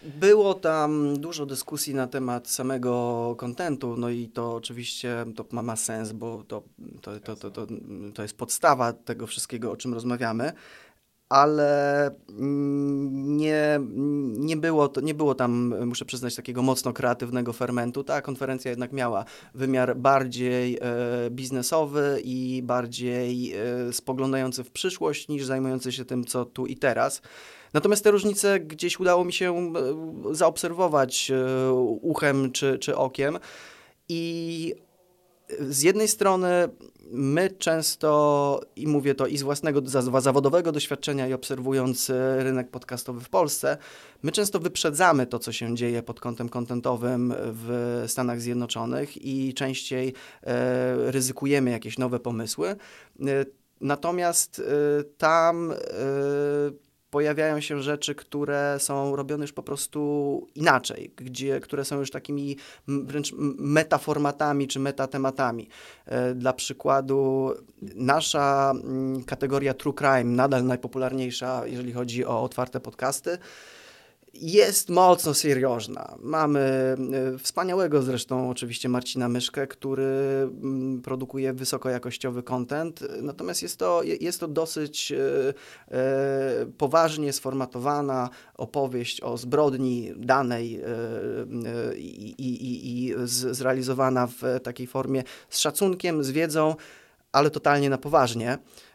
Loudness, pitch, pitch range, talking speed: -26 LUFS, 135 Hz, 125-145 Hz, 115 wpm